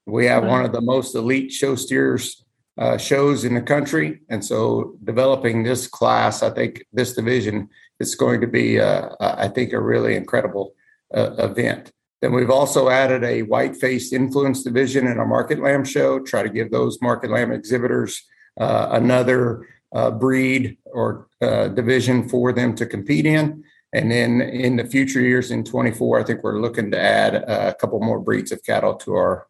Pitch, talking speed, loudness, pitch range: 125 Hz, 185 wpm, -20 LUFS, 120-135 Hz